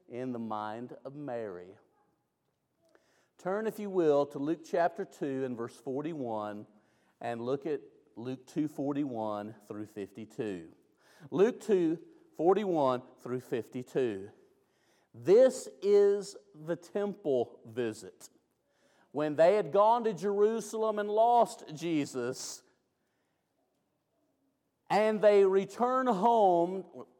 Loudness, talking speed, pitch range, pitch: -31 LUFS, 105 wpm, 125-210 Hz, 155 Hz